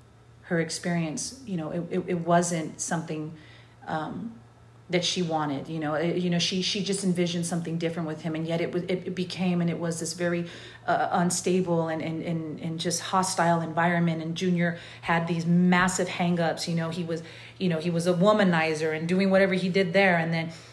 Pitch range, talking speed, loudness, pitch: 160-180 Hz, 205 wpm, -27 LUFS, 170 Hz